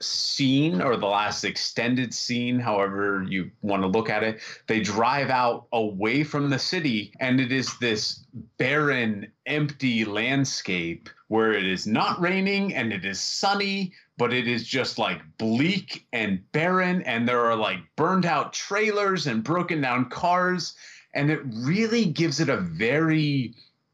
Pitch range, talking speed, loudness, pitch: 110-160 Hz, 155 wpm, -25 LUFS, 130 Hz